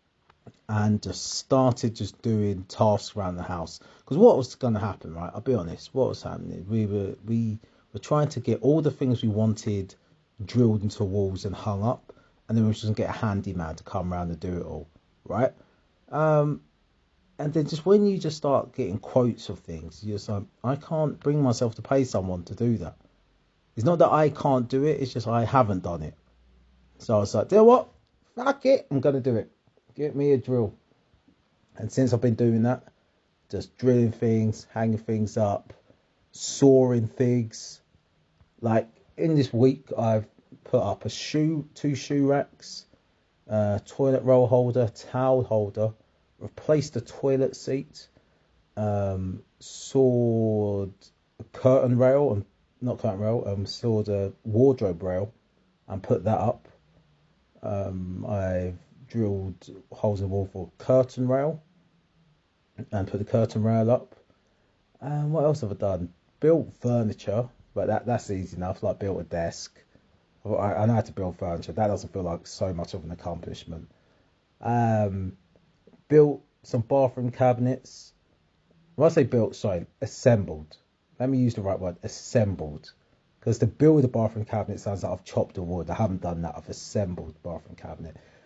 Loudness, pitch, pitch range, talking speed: -26 LUFS, 110 Hz, 95-130 Hz, 175 wpm